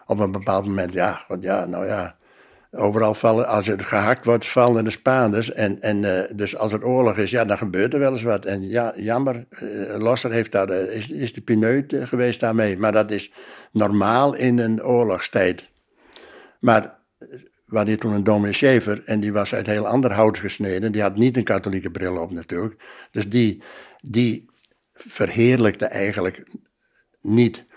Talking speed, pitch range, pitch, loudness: 175 wpm, 100-120 Hz, 110 Hz, -21 LUFS